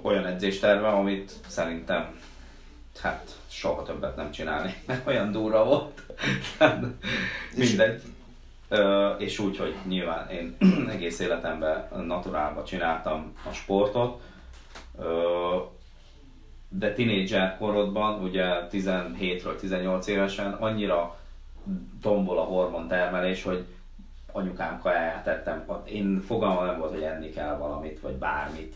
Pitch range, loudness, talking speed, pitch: 80-100 Hz, -28 LUFS, 105 wpm, 90 Hz